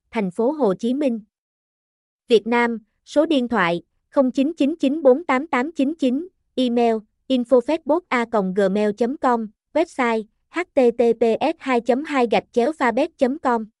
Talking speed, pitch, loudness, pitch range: 65 wpm, 250 Hz, -21 LUFS, 230-275 Hz